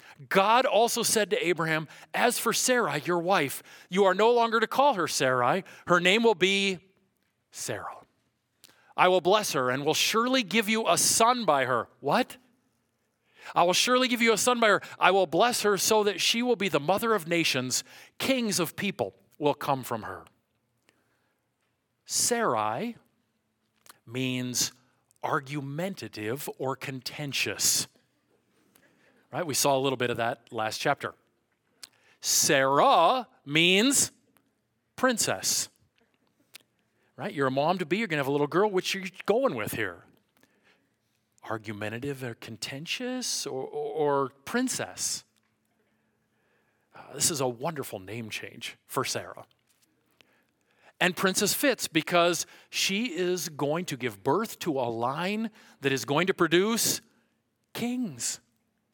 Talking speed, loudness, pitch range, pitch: 140 wpm, -26 LUFS, 130-215 Hz, 170 Hz